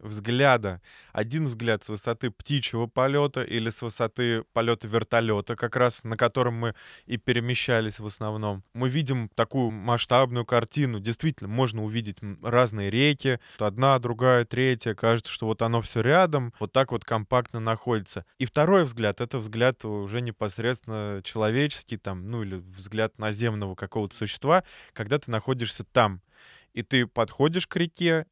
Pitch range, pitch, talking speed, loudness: 110-130 Hz, 115 Hz, 145 wpm, -26 LUFS